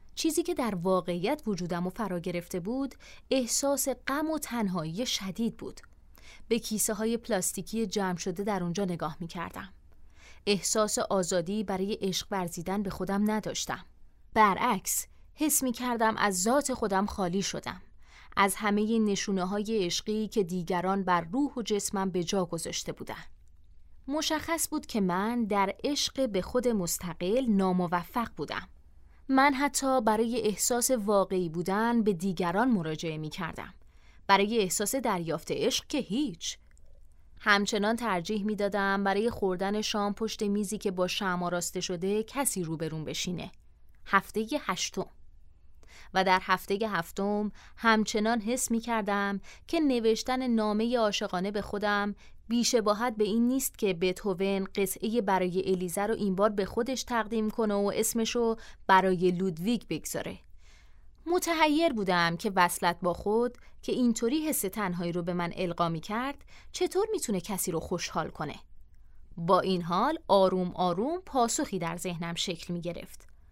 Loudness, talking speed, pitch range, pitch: -29 LUFS, 140 wpm, 180-230 Hz, 200 Hz